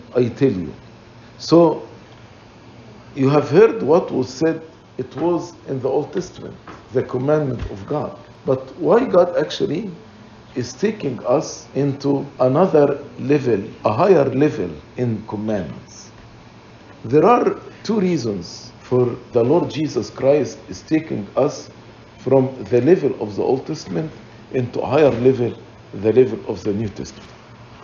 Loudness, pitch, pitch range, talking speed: -19 LUFS, 130 Hz, 115-150 Hz, 140 wpm